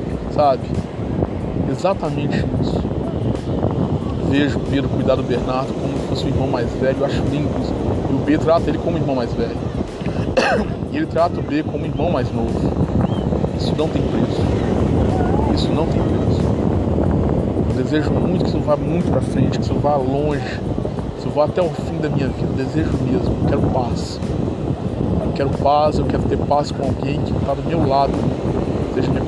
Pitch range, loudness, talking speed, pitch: 110-145 Hz, -19 LUFS, 185 wpm, 130 Hz